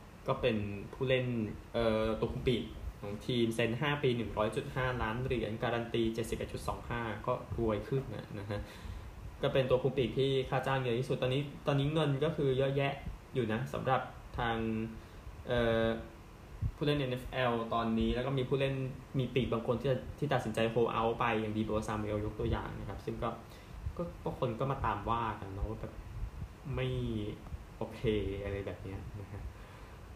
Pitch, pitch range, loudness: 115 Hz, 105-130 Hz, -35 LUFS